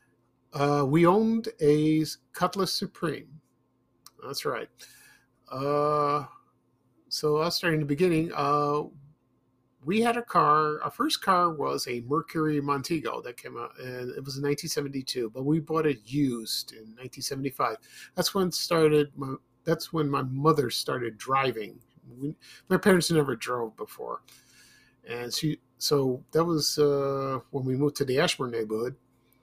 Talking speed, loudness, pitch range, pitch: 145 wpm, -27 LUFS, 130-160 Hz, 145 Hz